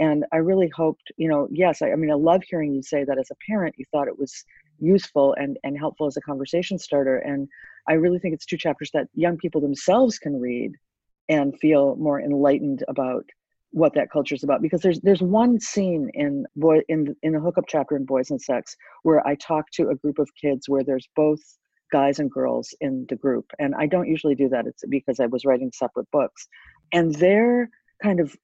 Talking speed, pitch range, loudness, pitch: 220 wpm, 140-175 Hz, -23 LUFS, 150 Hz